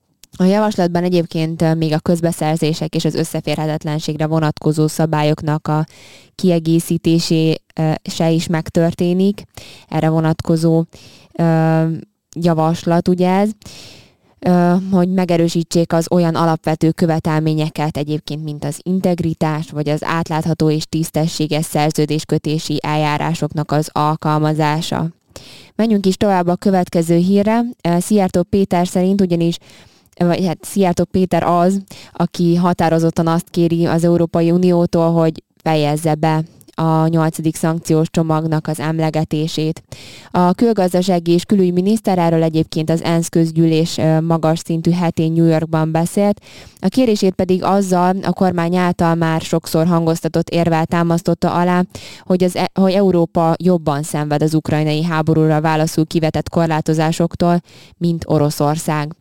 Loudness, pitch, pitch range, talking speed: -16 LUFS, 165 Hz, 155-175 Hz, 115 wpm